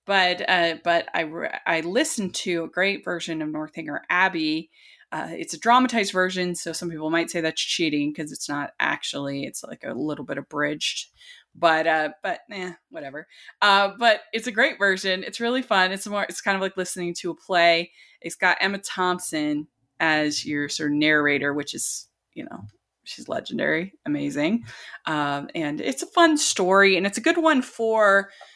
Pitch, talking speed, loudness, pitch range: 180 Hz, 185 wpm, -23 LUFS, 155-200 Hz